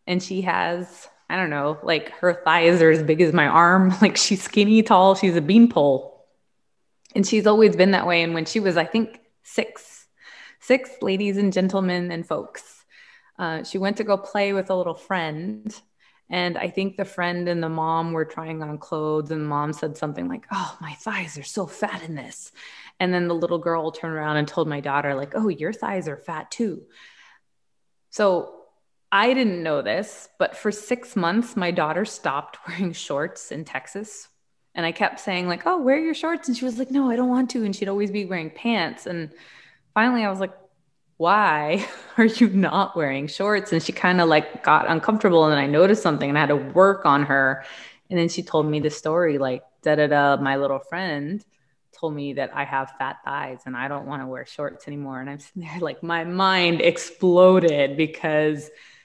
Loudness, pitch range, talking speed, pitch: -22 LUFS, 155-200 Hz, 205 wpm, 175 Hz